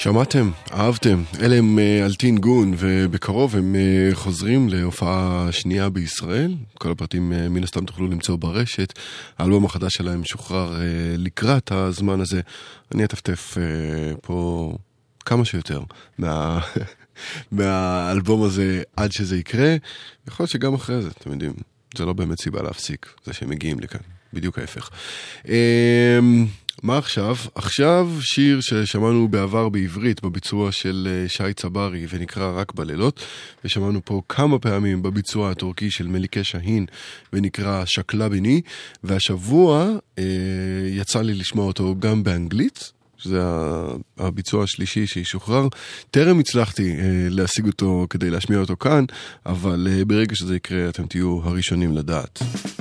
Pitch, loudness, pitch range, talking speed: 95 Hz, -21 LUFS, 90-110 Hz, 125 wpm